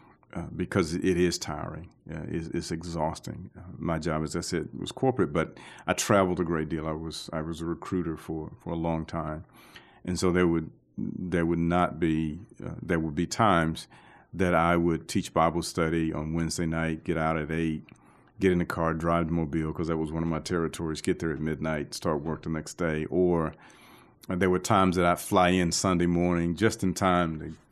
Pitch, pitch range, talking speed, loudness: 85 Hz, 80-90 Hz, 210 wpm, -28 LUFS